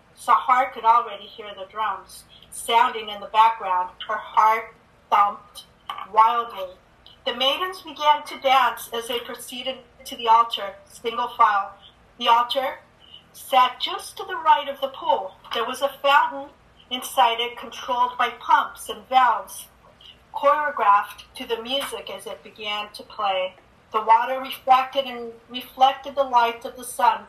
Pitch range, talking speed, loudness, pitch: 220-270 Hz, 145 wpm, -22 LUFS, 245 Hz